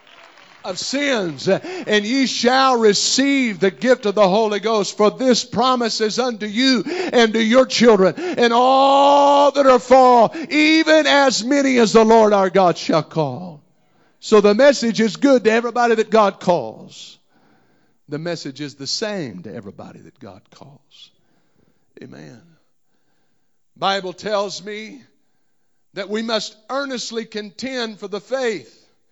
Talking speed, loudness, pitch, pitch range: 145 wpm, -16 LUFS, 225 Hz, 200-260 Hz